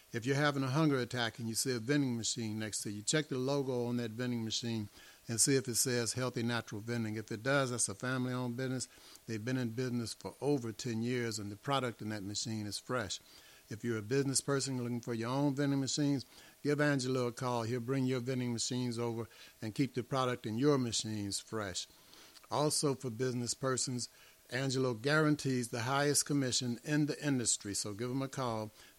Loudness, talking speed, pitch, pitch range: -35 LUFS, 205 wpm, 125 Hz, 115-135 Hz